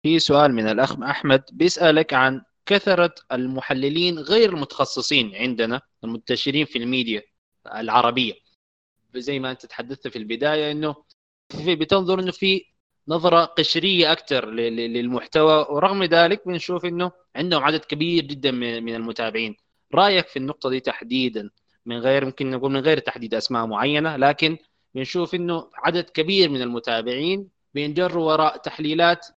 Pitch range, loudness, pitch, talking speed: 125-170 Hz, -21 LUFS, 145 Hz, 135 wpm